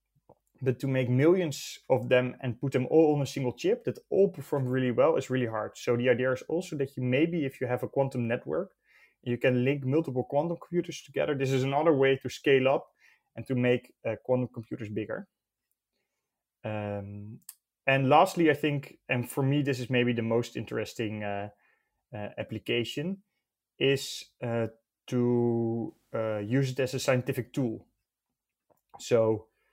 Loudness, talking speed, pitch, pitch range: -29 LUFS, 170 wpm, 130 Hz, 120-140 Hz